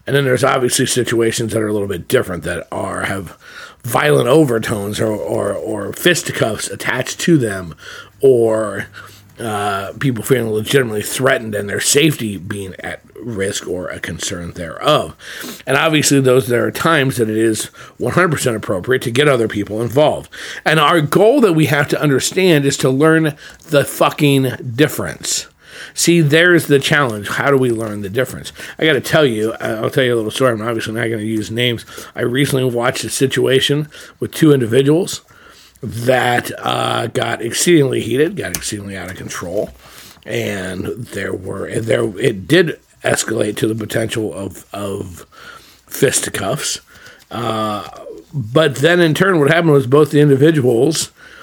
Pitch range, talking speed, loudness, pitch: 110-145 Hz, 165 wpm, -15 LUFS, 125 Hz